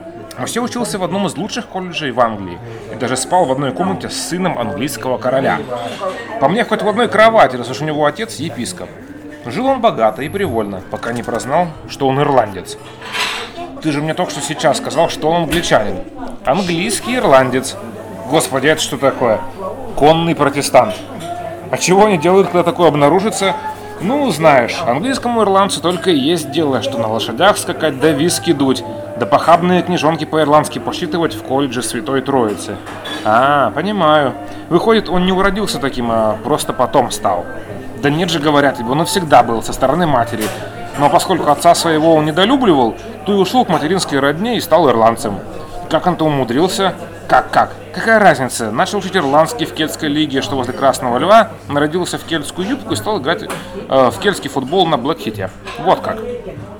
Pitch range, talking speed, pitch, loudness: 130-185 Hz, 170 wpm, 155 Hz, -15 LUFS